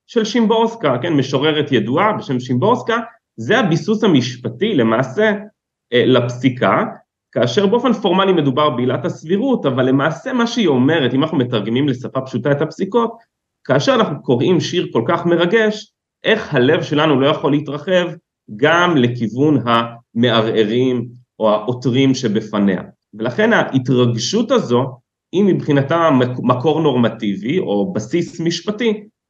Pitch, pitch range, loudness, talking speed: 145 Hz, 125-190 Hz, -16 LUFS, 120 wpm